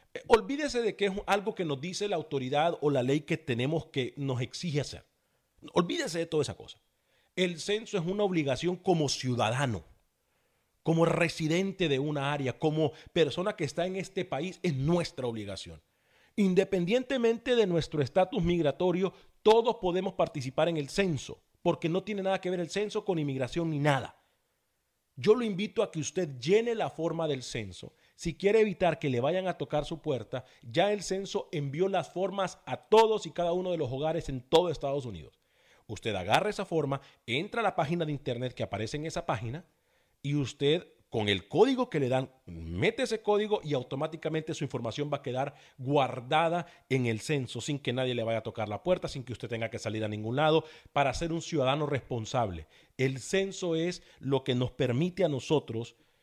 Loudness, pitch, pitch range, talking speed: -30 LUFS, 155 Hz, 130-185 Hz, 190 wpm